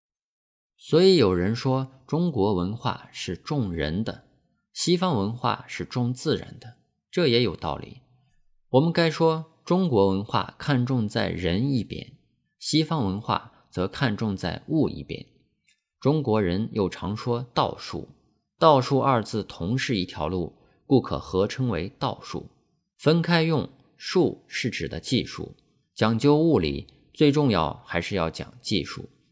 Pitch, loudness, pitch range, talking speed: 125 Hz, -25 LUFS, 105-150 Hz, 200 characters per minute